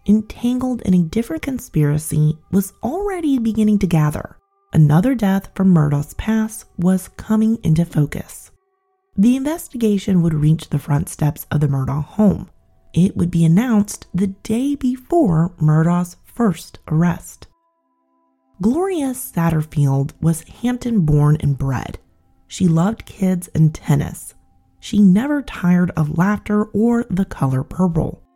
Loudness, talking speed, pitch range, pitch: -18 LUFS, 130 wpm, 150-220 Hz, 180 Hz